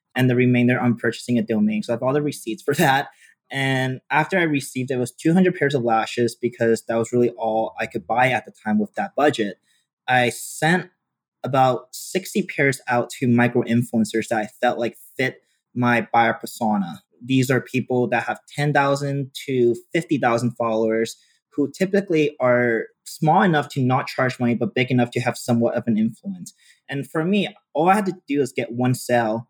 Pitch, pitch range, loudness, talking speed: 125 Hz, 120-145 Hz, -21 LUFS, 190 wpm